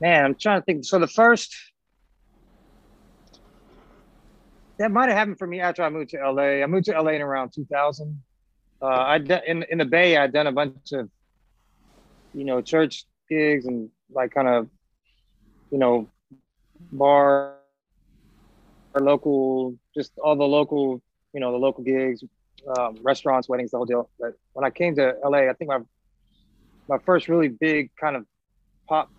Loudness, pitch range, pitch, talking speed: -22 LUFS, 130-155 Hz, 140 Hz, 165 wpm